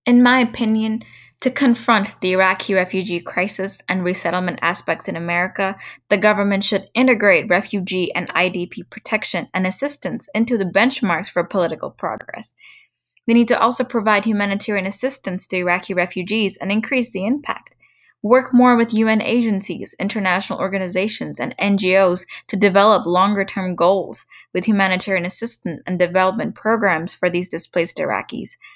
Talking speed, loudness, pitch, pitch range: 140 wpm, -18 LUFS, 195 Hz, 185-225 Hz